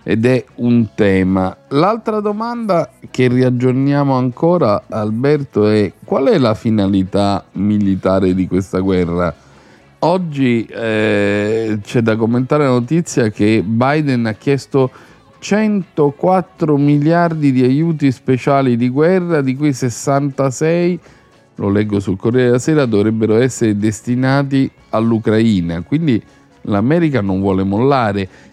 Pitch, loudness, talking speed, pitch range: 125 Hz, -15 LUFS, 115 wpm, 105-145 Hz